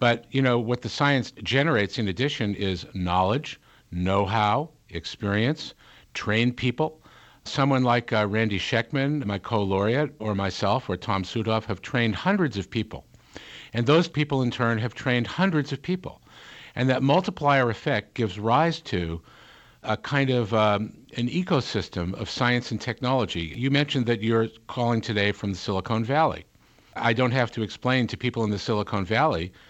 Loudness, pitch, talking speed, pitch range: -25 LUFS, 115 Hz, 160 wpm, 105-135 Hz